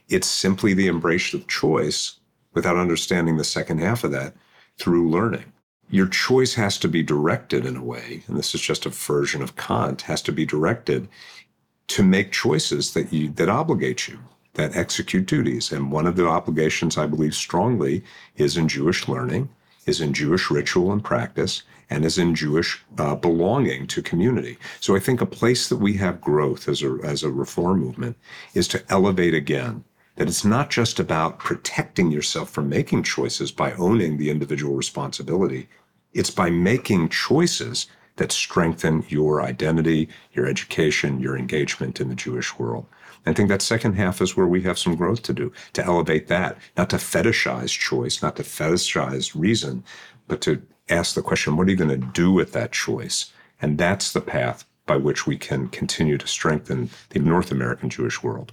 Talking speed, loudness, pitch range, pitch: 180 wpm, -22 LUFS, 75-95 Hz, 80 Hz